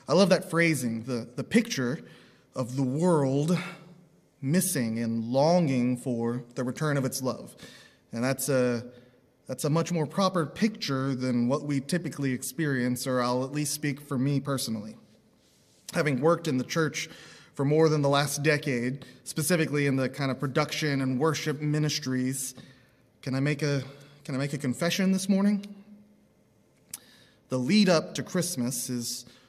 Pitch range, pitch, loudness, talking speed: 130-160 Hz, 140 Hz, -28 LUFS, 160 wpm